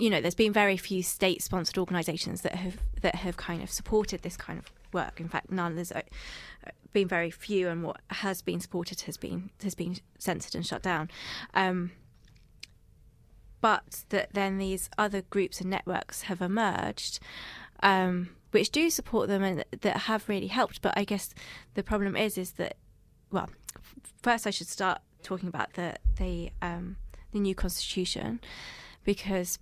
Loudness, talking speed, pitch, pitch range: -31 LUFS, 165 wpm, 185 Hz, 175-200 Hz